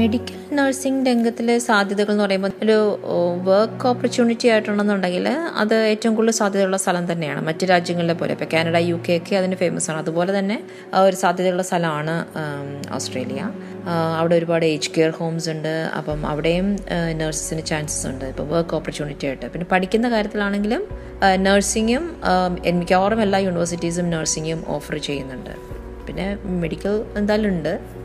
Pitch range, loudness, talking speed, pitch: 165-205 Hz, -20 LUFS, 135 wpm, 185 Hz